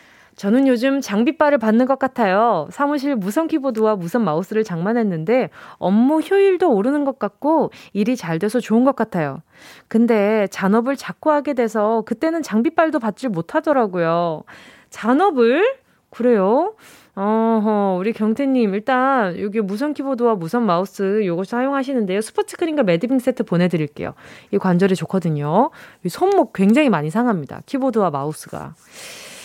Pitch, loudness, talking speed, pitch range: 230 Hz, -19 LUFS, 330 characters per minute, 200-275 Hz